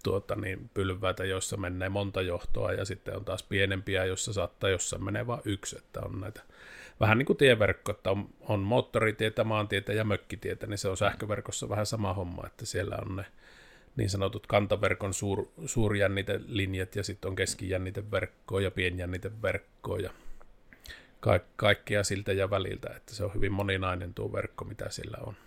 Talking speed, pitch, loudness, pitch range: 165 wpm, 100 Hz, -31 LUFS, 95-105 Hz